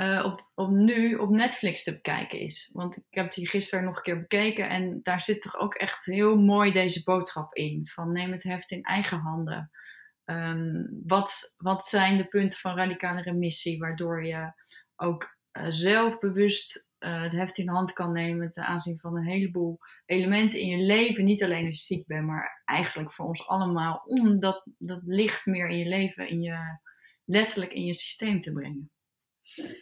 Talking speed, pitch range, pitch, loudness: 190 wpm, 170-200 Hz, 185 Hz, -28 LUFS